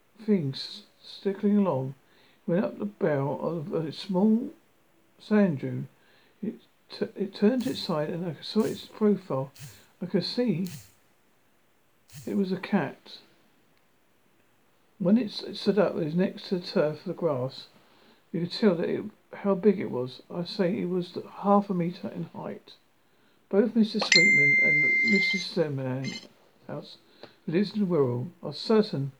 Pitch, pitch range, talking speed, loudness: 190 Hz, 165-205 Hz, 150 wpm, -27 LUFS